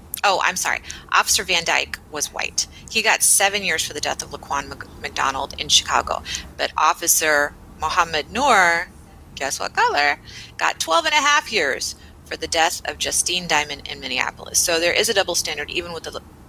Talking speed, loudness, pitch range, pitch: 180 wpm, -19 LUFS, 150-185 Hz, 165 Hz